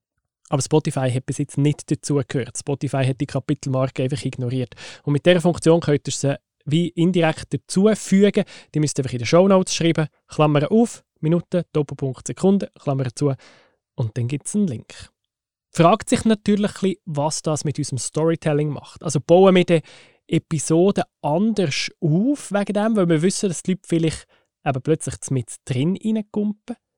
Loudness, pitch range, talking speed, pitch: -21 LUFS, 140-180 Hz, 165 wpm, 155 Hz